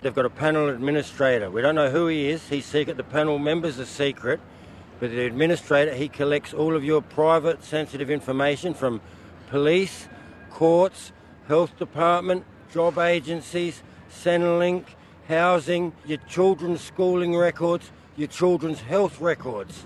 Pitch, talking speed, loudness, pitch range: 155 Hz, 140 wpm, -24 LUFS, 140-170 Hz